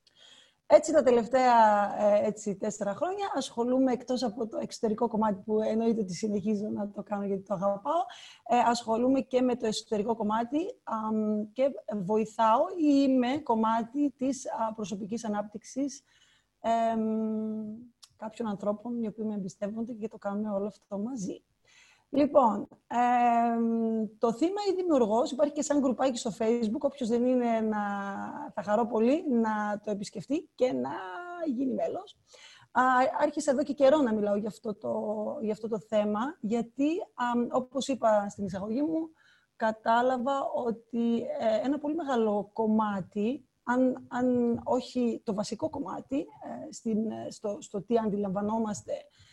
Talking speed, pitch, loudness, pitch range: 140 wpm, 230 Hz, -29 LUFS, 215-270 Hz